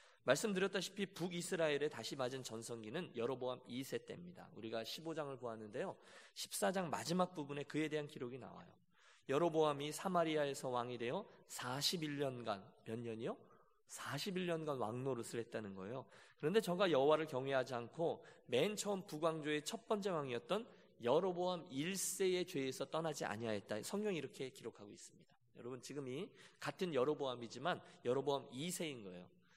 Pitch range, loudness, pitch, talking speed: 125-175 Hz, -42 LUFS, 145 Hz, 350 characters per minute